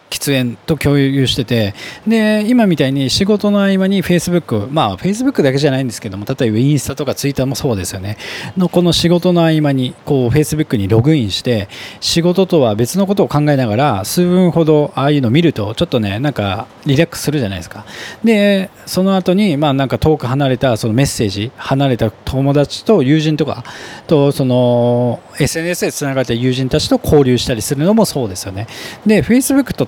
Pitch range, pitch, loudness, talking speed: 120-175 Hz, 140 Hz, -14 LUFS, 410 characters per minute